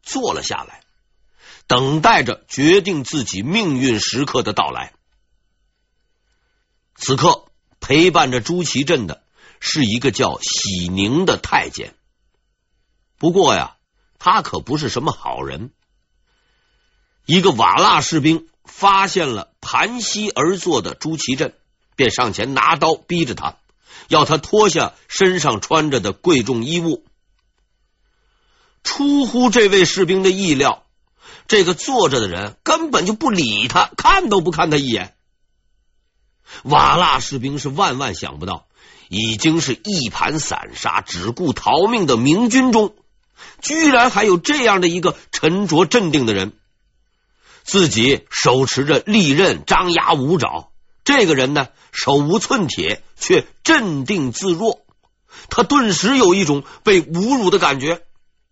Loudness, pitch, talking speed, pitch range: -16 LUFS, 170 Hz, 195 characters per minute, 135-210 Hz